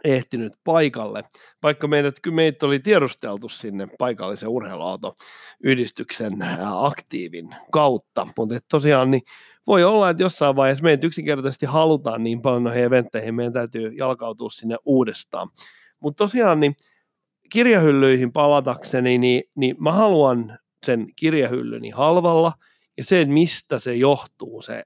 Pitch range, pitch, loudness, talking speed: 120-155 Hz, 135 Hz, -20 LUFS, 120 wpm